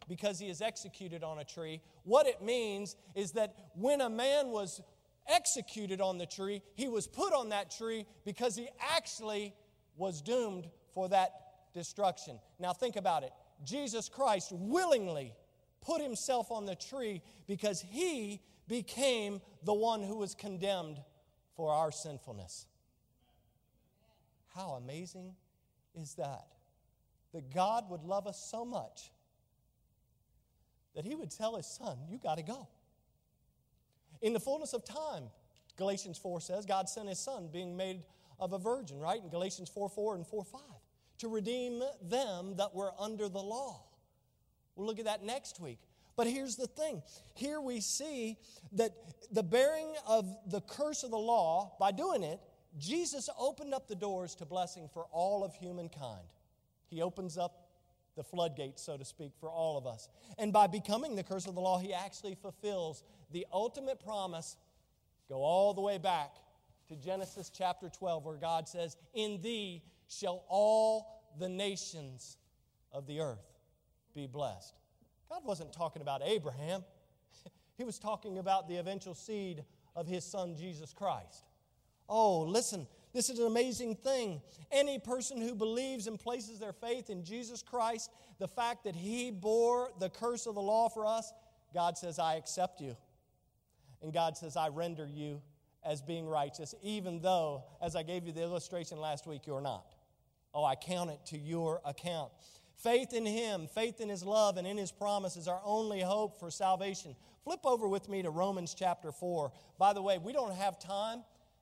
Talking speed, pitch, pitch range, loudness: 165 wpm, 190 Hz, 160-220 Hz, -37 LUFS